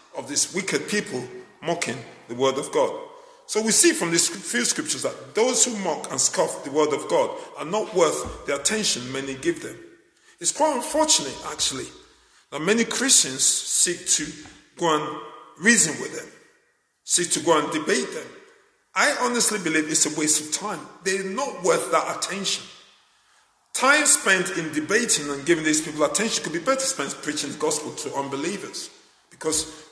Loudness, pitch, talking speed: -22 LUFS, 210 Hz, 170 wpm